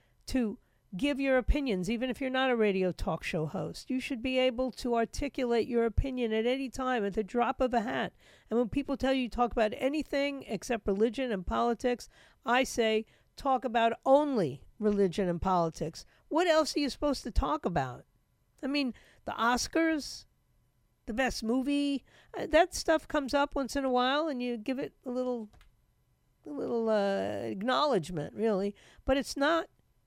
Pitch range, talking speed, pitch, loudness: 220-270 Hz, 175 wpm, 250 Hz, -31 LUFS